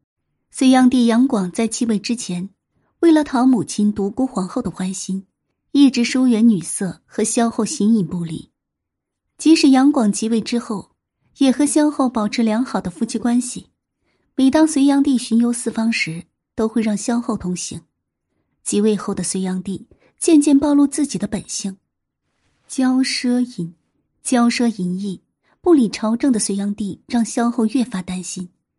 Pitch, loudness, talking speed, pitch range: 230 Hz, -18 LUFS, 230 characters per minute, 200-255 Hz